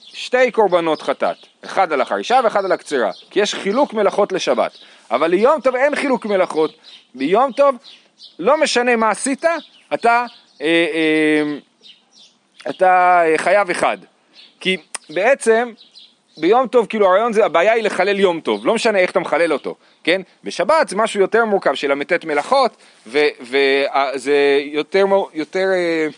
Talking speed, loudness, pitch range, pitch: 145 wpm, -17 LUFS, 160-240 Hz, 195 Hz